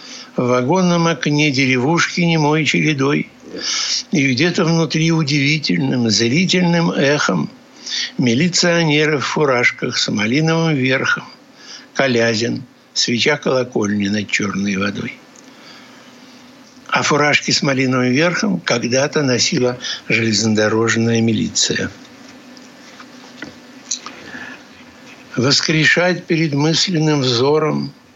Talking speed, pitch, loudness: 80 wpm, 160 Hz, -16 LUFS